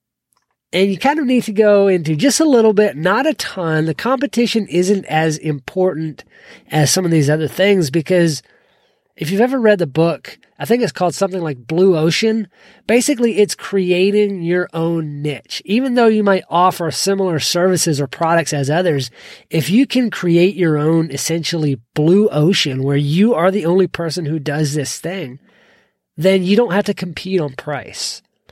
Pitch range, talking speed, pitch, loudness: 160-205 Hz, 180 wpm, 180 Hz, -16 LUFS